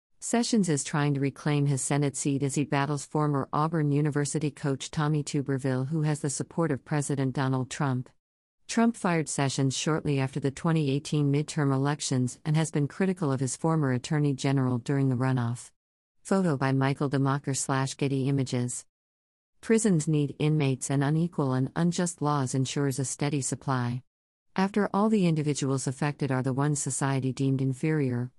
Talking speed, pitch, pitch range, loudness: 160 wpm, 140 Hz, 135-150 Hz, -28 LUFS